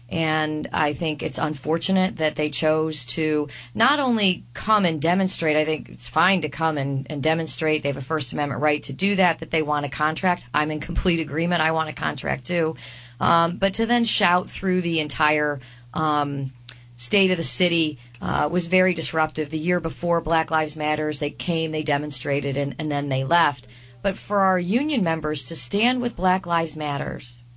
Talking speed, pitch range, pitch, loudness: 195 wpm, 145-175 Hz, 155 Hz, -22 LUFS